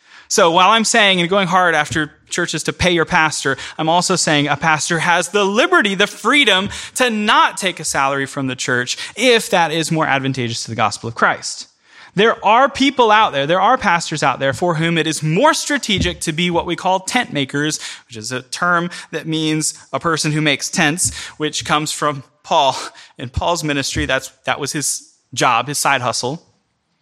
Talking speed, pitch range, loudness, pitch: 200 wpm, 145-185 Hz, -16 LUFS, 160 Hz